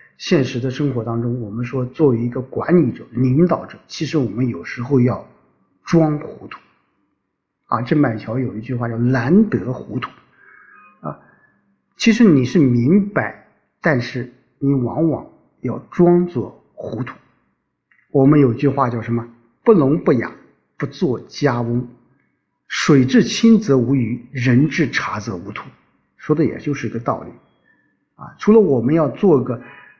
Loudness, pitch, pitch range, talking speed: -18 LUFS, 130 Hz, 120-160 Hz, 210 characters per minute